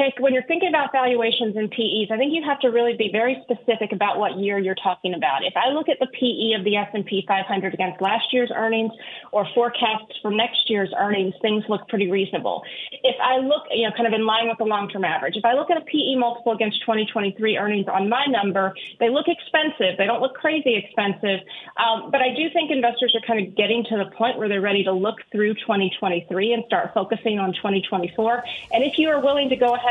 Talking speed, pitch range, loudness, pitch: 225 wpm, 205-250 Hz, -21 LUFS, 225 Hz